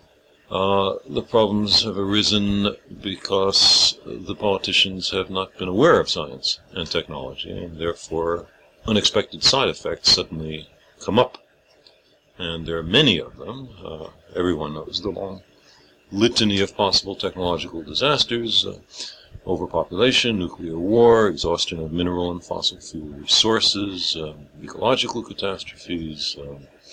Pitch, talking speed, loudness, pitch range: 90 Hz, 125 wpm, -20 LUFS, 80-100 Hz